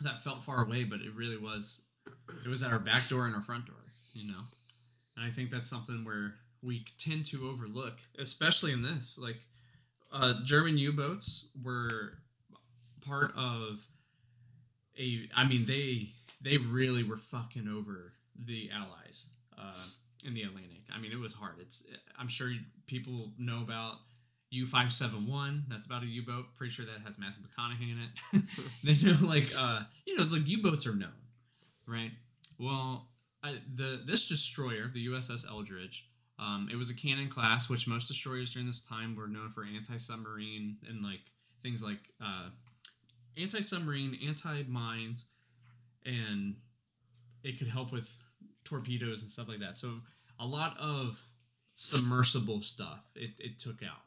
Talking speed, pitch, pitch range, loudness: 165 wpm, 120 Hz, 115-130 Hz, -35 LUFS